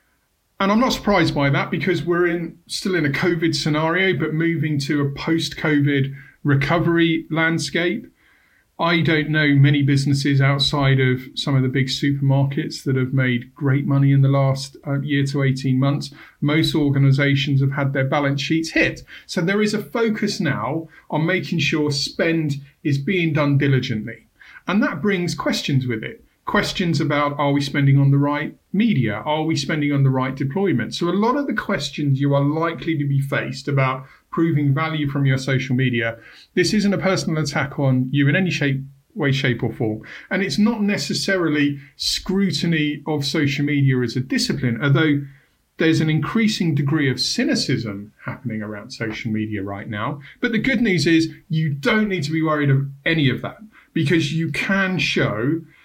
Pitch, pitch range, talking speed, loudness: 150 Hz, 140-170 Hz, 180 wpm, -20 LUFS